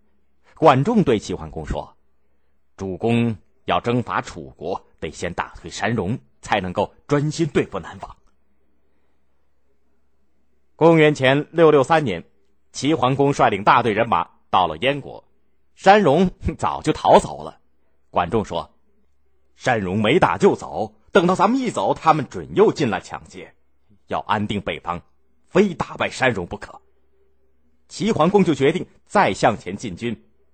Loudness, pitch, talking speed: -20 LUFS, 80 Hz, 200 characters per minute